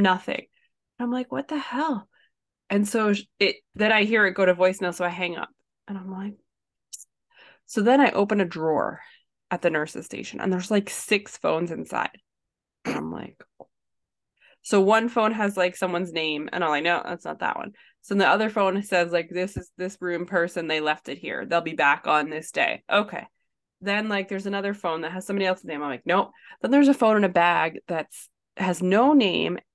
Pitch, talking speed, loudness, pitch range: 190 Hz, 210 wpm, -24 LUFS, 175-210 Hz